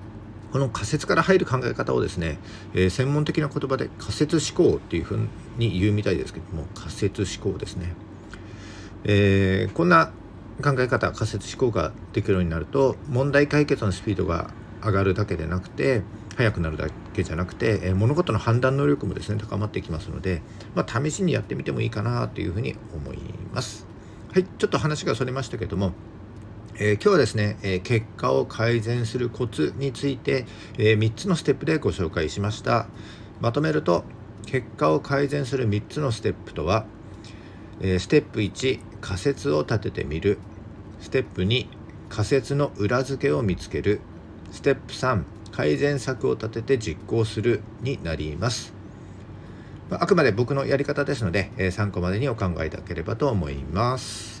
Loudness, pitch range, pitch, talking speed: -25 LUFS, 100-130 Hz, 110 Hz, 340 characters per minute